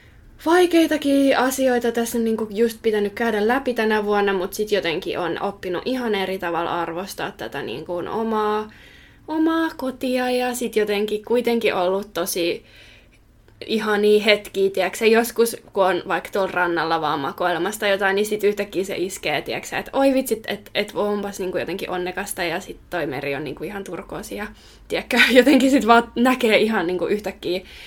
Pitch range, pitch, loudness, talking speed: 185-235 Hz, 210 Hz, -21 LUFS, 155 wpm